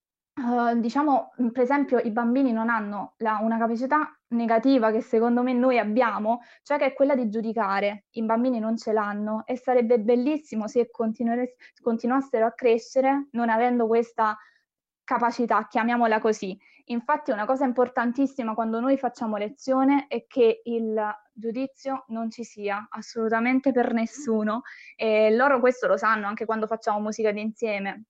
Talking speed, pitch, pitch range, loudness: 150 wpm, 235 Hz, 220-255 Hz, -25 LUFS